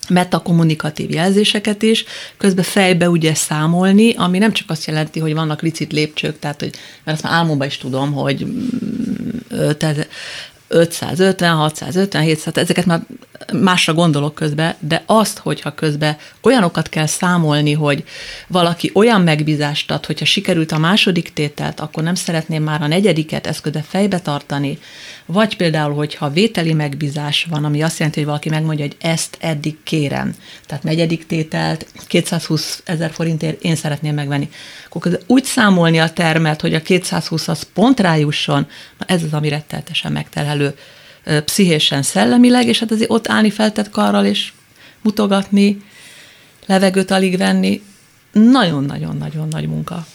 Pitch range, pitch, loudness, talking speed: 150-190 Hz, 165 Hz, -16 LUFS, 140 wpm